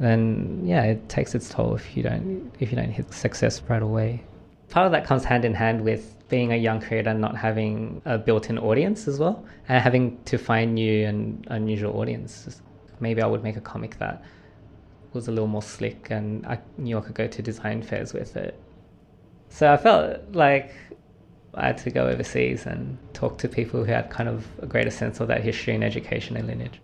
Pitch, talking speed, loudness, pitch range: 110 Hz, 210 wpm, -25 LUFS, 110-125 Hz